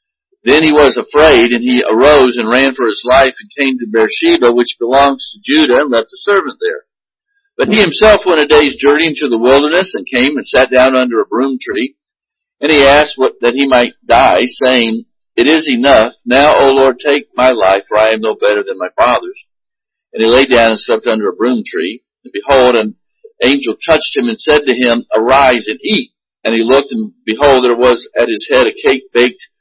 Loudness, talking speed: -10 LUFS, 215 wpm